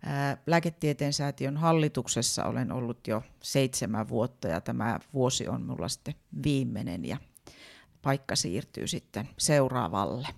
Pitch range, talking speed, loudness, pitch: 125-145 Hz, 120 wpm, -30 LUFS, 135 Hz